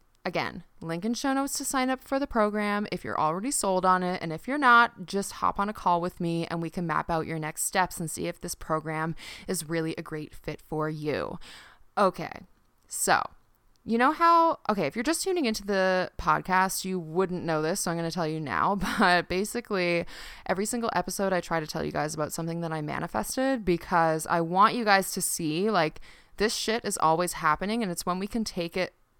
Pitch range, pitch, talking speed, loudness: 165-215 Hz, 185 Hz, 220 wpm, -27 LUFS